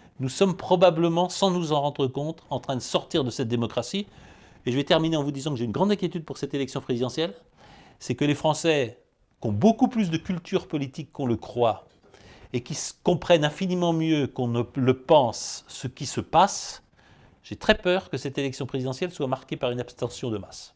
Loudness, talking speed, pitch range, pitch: -26 LUFS, 210 wpm, 130-175 Hz, 145 Hz